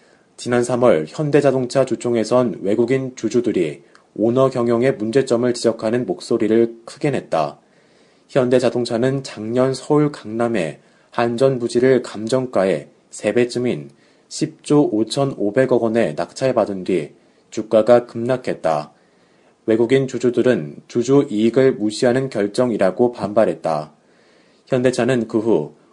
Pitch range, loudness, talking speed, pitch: 115-130 Hz, -19 LUFS, 260 characters per minute, 120 Hz